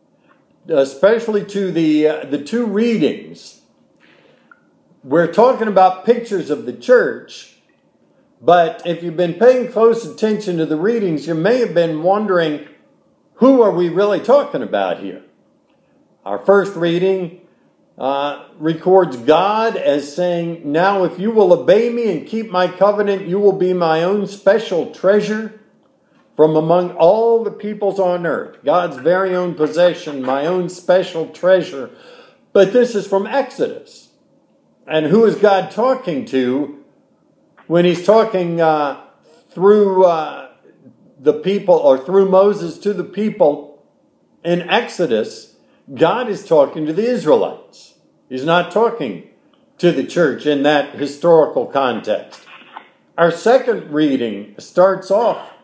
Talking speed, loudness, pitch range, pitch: 135 wpm, -16 LUFS, 165-210 Hz, 185 Hz